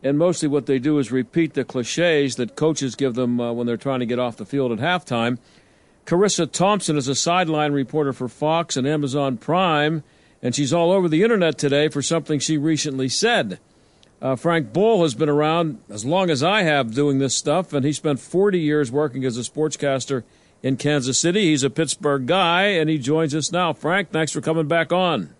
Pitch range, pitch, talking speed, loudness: 135-165 Hz, 150 Hz, 210 wpm, -20 LUFS